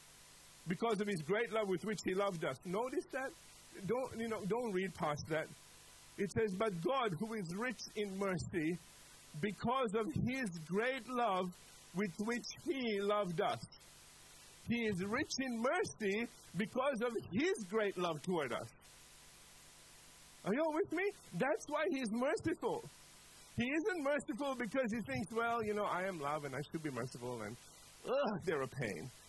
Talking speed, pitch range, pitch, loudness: 165 wpm, 180-250 Hz, 215 Hz, -39 LUFS